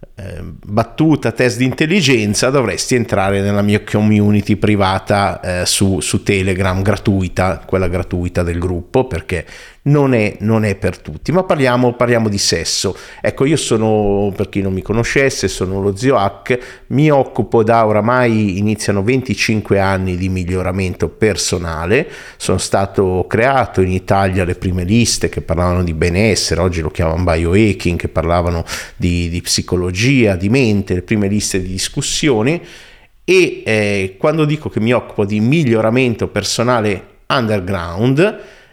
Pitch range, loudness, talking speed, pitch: 95-115 Hz, -15 LUFS, 145 wpm, 105 Hz